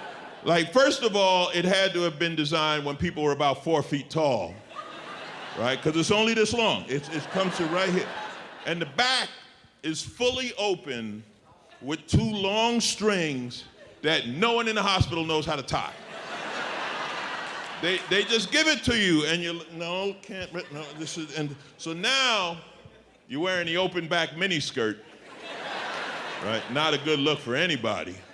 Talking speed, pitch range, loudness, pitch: 170 wpm, 150-200 Hz, -26 LUFS, 170 Hz